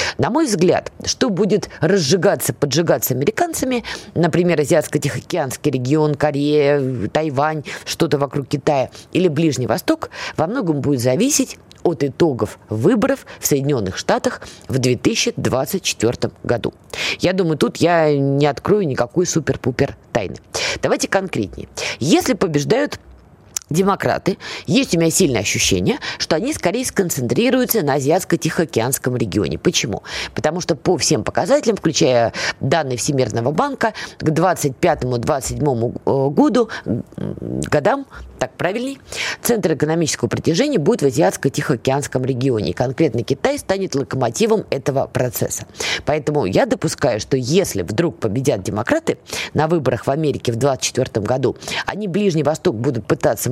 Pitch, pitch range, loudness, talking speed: 150 Hz, 130-180 Hz, -18 LUFS, 120 wpm